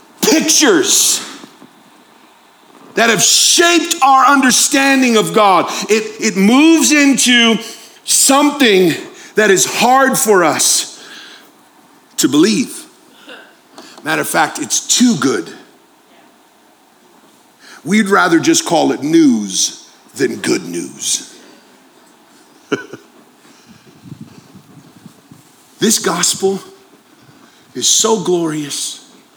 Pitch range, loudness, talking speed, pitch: 220-330 Hz, -11 LUFS, 80 wpm, 280 Hz